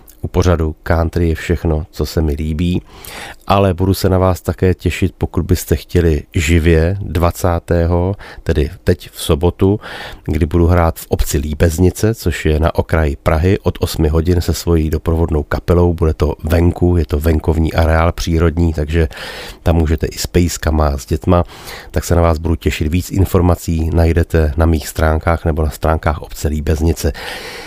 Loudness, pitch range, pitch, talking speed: -15 LUFS, 80-90 Hz, 85 Hz, 165 wpm